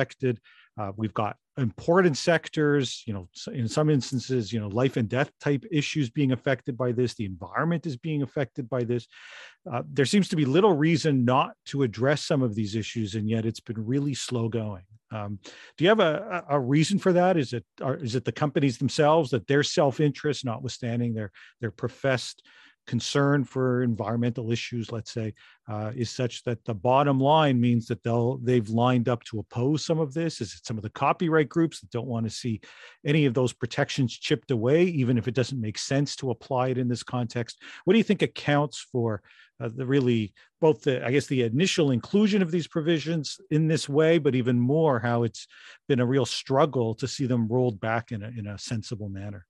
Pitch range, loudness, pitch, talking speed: 115-145 Hz, -26 LUFS, 125 Hz, 205 wpm